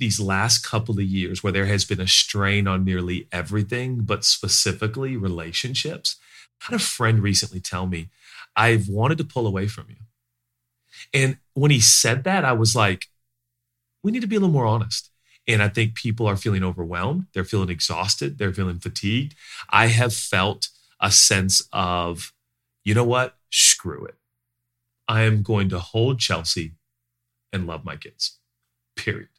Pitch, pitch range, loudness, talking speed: 110 Hz, 95-120 Hz, -21 LUFS, 165 wpm